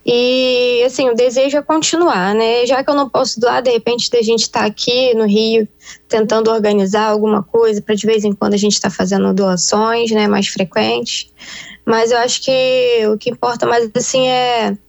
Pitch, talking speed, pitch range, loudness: 230 Hz, 200 wpm, 215-245 Hz, -14 LUFS